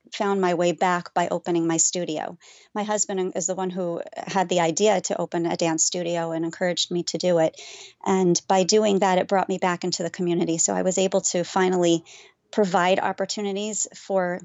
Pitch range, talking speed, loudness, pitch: 175-195 Hz, 200 wpm, -23 LUFS, 185 Hz